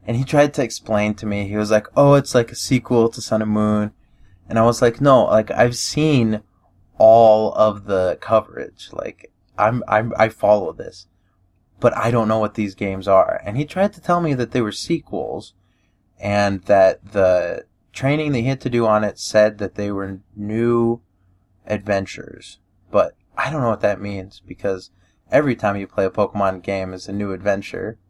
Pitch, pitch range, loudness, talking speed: 105 Hz, 95-120 Hz, -19 LUFS, 190 wpm